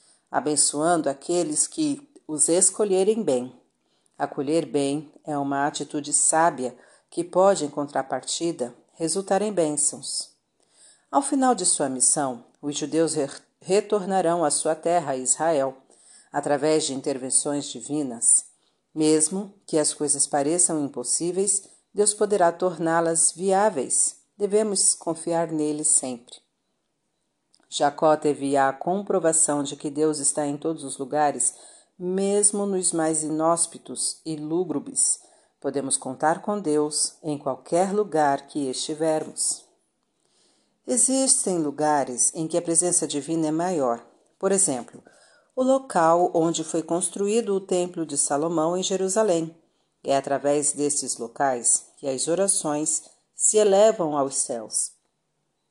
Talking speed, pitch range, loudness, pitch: 115 wpm, 145-180 Hz, -23 LUFS, 155 Hz